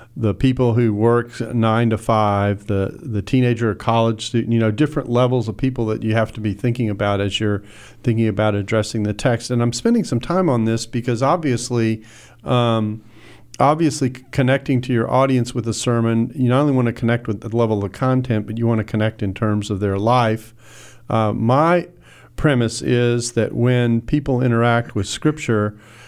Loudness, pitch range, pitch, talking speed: -19 LUFS, 110-125 Hz, 115 Hz, 190 wpm